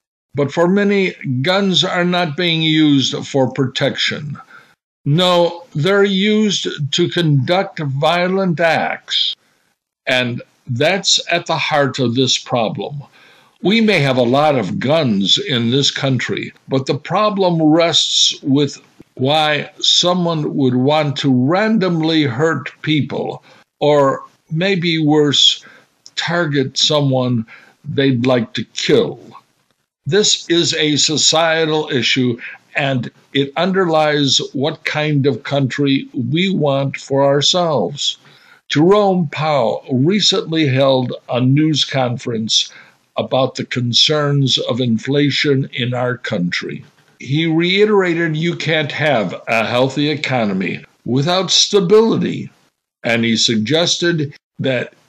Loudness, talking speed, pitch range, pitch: -15 LUFS, 110 wpm, 130-170 Hz, 150 Hz